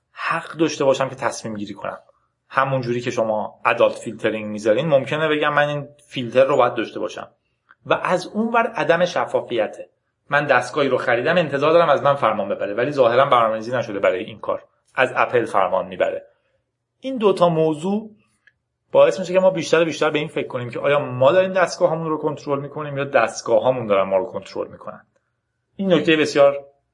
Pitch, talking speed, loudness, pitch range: 145 Hz, 185 wpm, -20 LUFS, 125-175 Hz